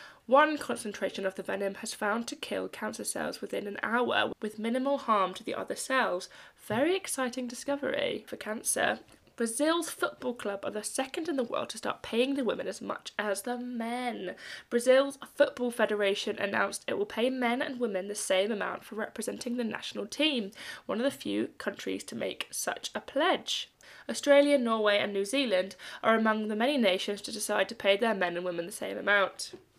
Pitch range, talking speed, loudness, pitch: 205-275 Hz, 190 wpm, -30 LUFS, 235 Hz